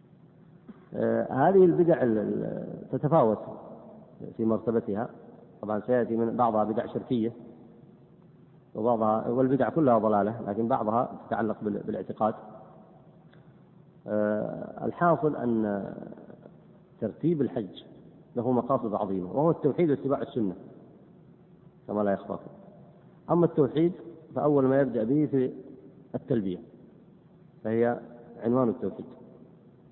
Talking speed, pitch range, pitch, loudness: 90 wpm, 115-165 Hz, 130 Hz, -27 LUFS